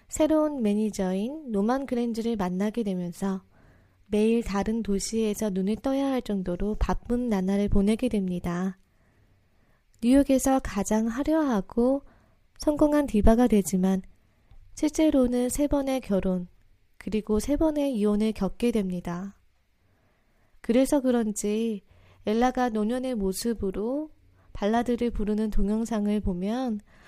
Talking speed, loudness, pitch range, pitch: 260 characters per minute, -26 LUFS, 190-245 Hz, 215 Hz